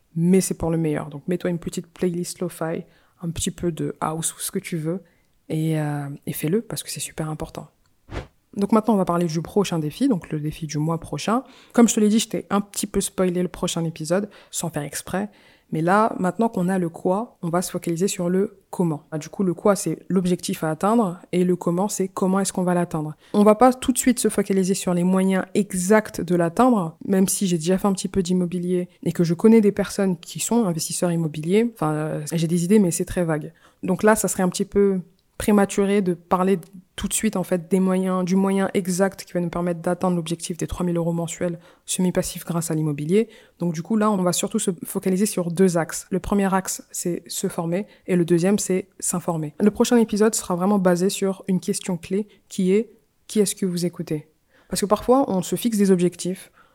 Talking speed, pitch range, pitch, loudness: 230 wpm, 175-200 Hz, 185 Hz, -22 LUFS